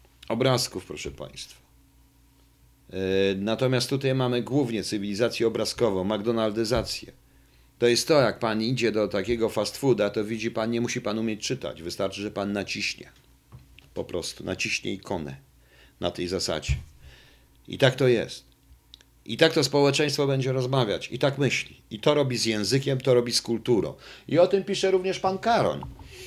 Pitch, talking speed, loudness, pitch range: 115 Hz, 160 wpm, -25 LUFS, 100-135 Hz